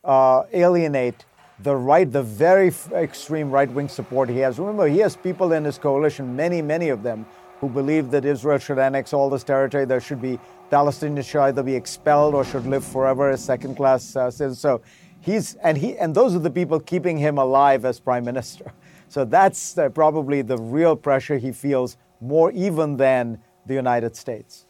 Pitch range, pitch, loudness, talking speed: 130-155 Hz, 140 Hz, -21 LUFS, 195 wpm